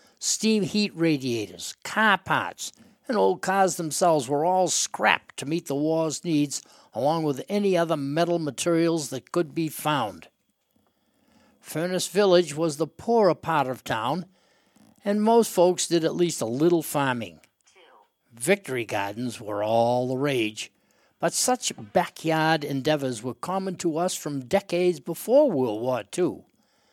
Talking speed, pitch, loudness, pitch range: 145 wpm, 165 Hz, -25 LUFS, 140-180 Hz